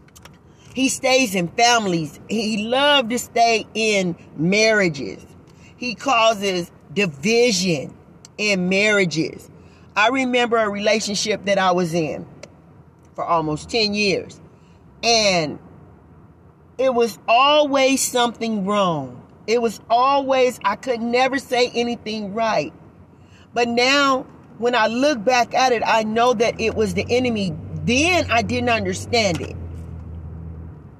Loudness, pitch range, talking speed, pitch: -19 LUFS, 190-245 Hz, 120 wpm, 225 Hz